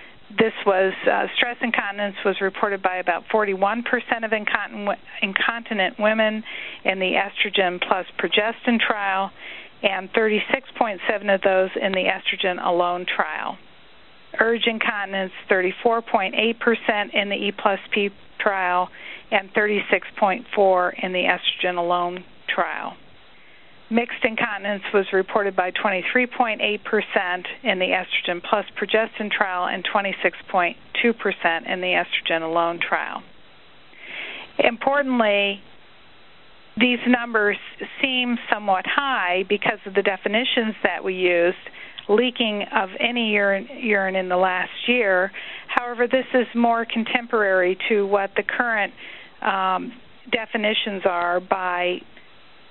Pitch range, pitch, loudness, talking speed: 190-230 Hz, 205 Hz, -22 LUFS, 115 wpm